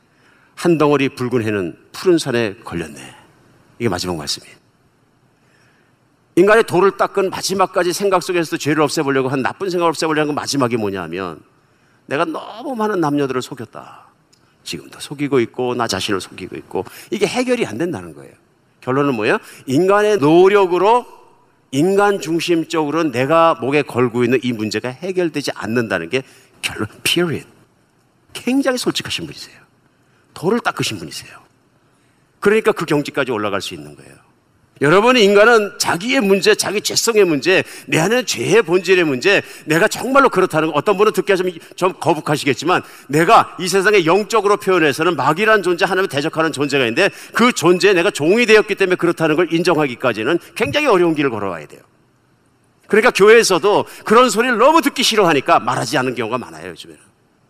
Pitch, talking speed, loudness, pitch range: 170 Hz, 380 characters per minute, -16 LUFS, 140-205 Hz